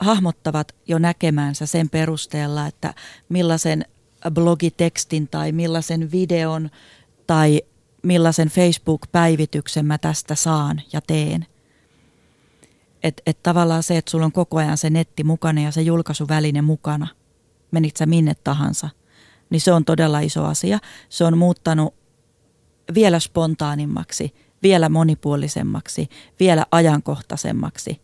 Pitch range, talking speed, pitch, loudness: 150-165 Hz, 115 wpm, 160 Hz, -19 LUFS